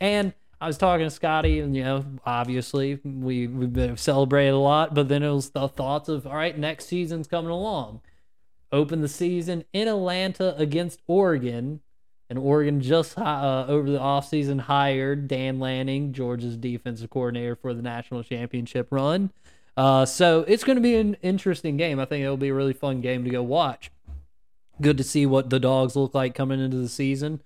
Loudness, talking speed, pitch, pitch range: -24 LUFS, 190 wpm, 140 Hz, 130-160 Hz